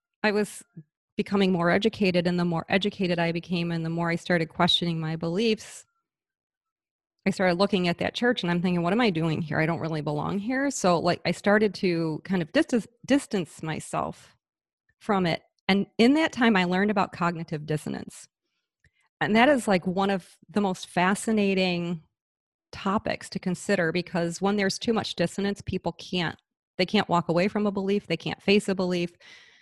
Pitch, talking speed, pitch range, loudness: 185 Hz, 185 wpm, 170-205 Hz, -26 LUFS